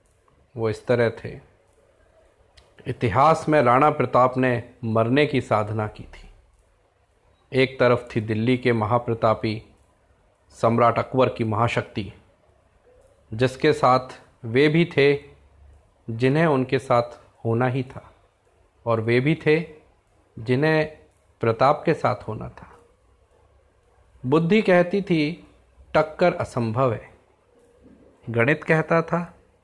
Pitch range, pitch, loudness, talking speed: 110-145 Hz, 120 Hz, -22 LUFS, 110 wpm